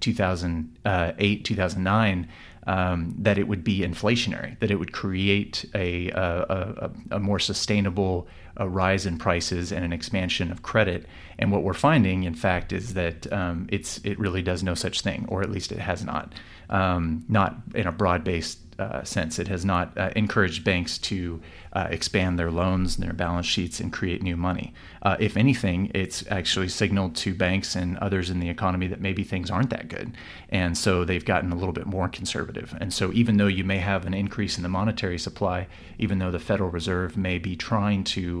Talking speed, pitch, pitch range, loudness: 195 wpm, 95 Hz, 90-100 Hz, -26 LUFS